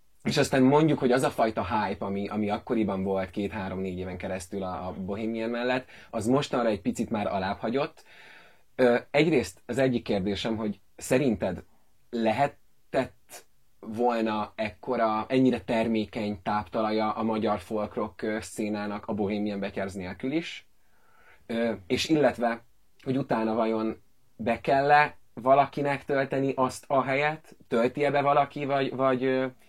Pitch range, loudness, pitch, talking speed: 105-130 Hz, -28 LUFS, 115 Hz, 130 wpm